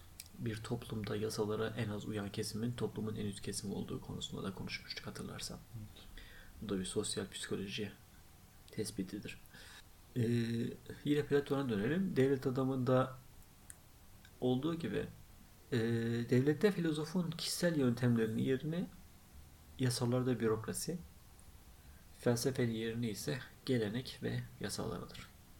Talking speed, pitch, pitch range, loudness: 105 wpm, 110 Hz, 100-130 Hz, -38 LUFS